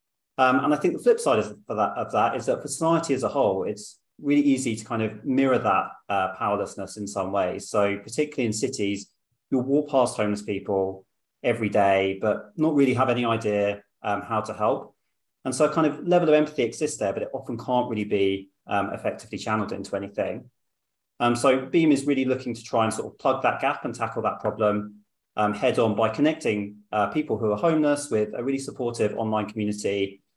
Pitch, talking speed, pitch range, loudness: 115 Hz, 210 wpm, 105-135 Hz, -25 LUFS